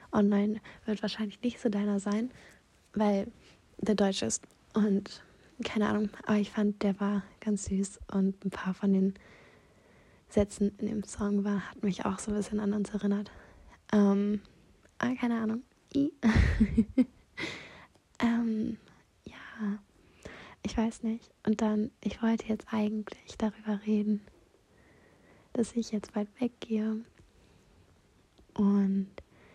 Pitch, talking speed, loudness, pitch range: 210 Hz, 130 wpm, -31 LUFS, 200-220 Hz